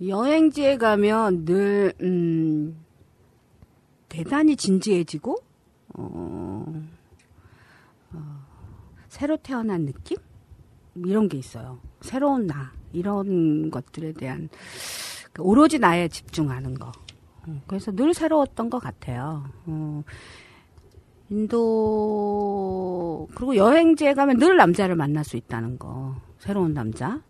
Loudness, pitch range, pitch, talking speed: -23 LUFS, 130-215 Hz, 170 Hz, 205 characters per minute